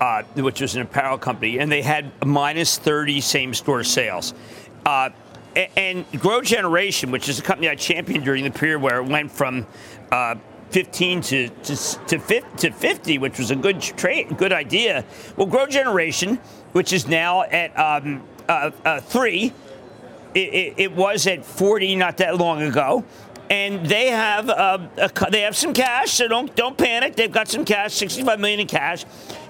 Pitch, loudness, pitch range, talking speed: 175 Hz, -20 LUFS, 140-205 Hz, 180 wpm